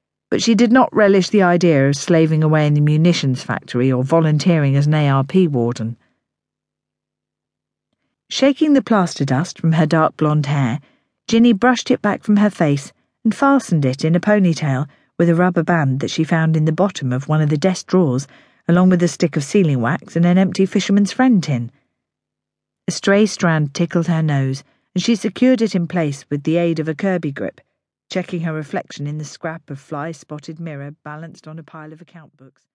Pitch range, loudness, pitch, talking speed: 150-190 Hz, -17 LUFS, 165 Hz, 195 wpm